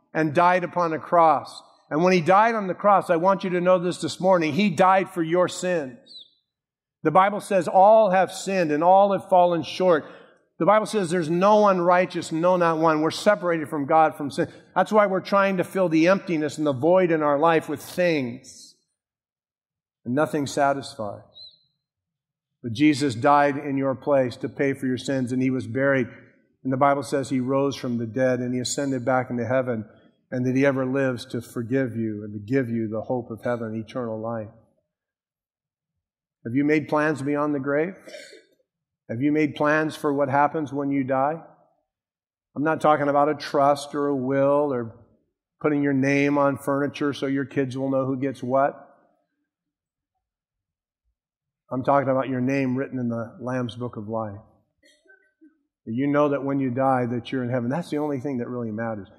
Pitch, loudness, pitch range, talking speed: 145 Hz, -23 LUFS, 130-165 Hz, 190 wpm